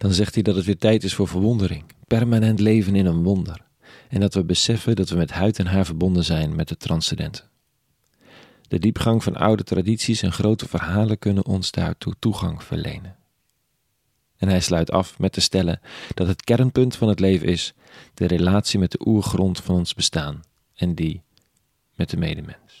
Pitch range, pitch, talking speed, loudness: 90-110 Hz, 95 Hz, 185 wpm, -21 LUFS